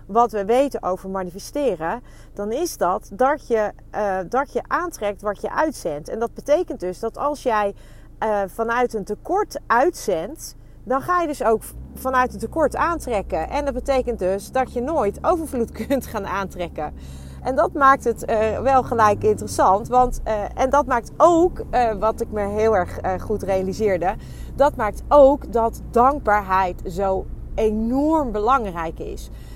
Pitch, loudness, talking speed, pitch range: 230 Hz, -21 LUFS, 165 wpm, 205-270 Hz